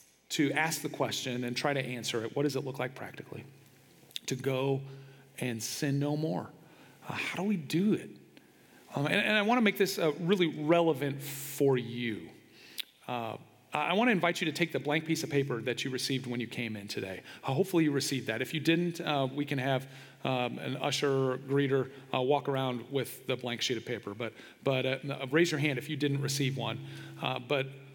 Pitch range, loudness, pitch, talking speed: 130-150 Hz, -32 LUFS, 135 Hz, 215 wpm